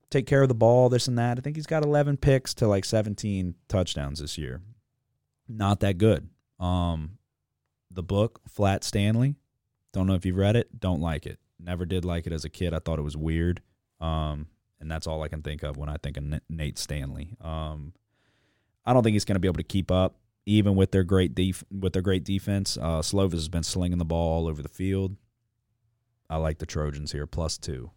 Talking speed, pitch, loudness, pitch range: 220 wpm, 95 Hz, -27 LUFS, 80-110 Hz